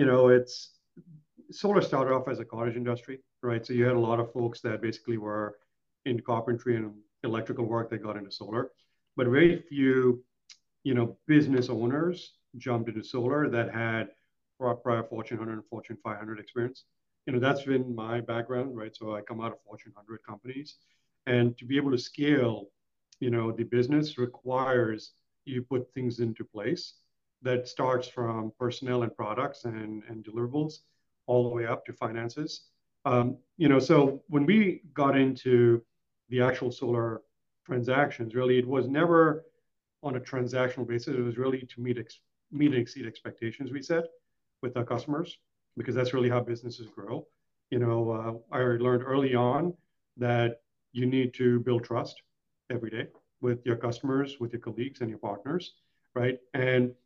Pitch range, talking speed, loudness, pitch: 115-135 Hz, 170 wpm, -29 LUFS, 125 Hz